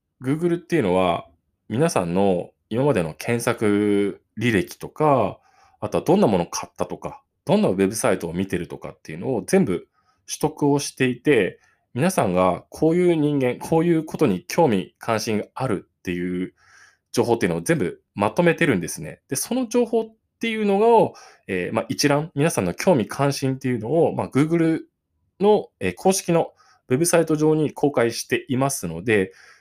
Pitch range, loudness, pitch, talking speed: 100-165 Hz, -22 LUFS, 140 Hz, 350 characters per minute